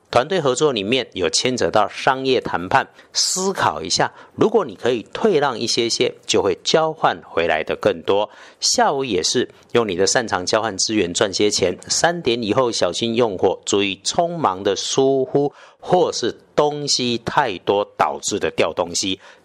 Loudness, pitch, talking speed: -19 LUFS, 150 Hz, 245 characters per minute